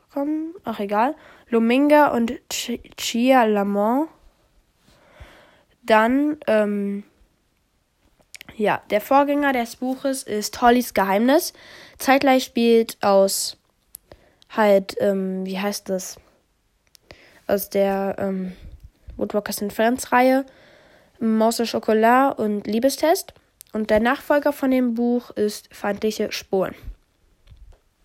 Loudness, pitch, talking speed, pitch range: -21 LUFS, 230 Hz, 100 wpm, 205-270 Hz